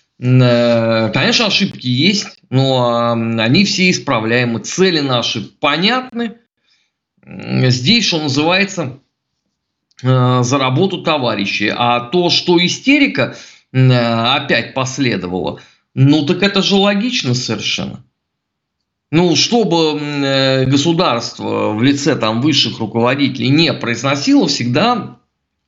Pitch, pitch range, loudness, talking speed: 135 Hz, 120-175 Hz, -14 LUFS, 90 wpm